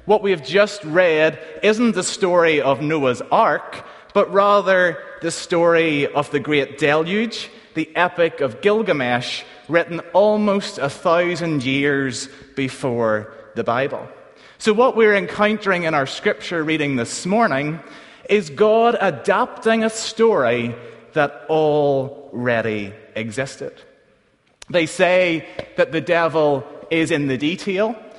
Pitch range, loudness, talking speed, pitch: 140-205 Hz, -19 LUFS, 125 wpm, 165 Hz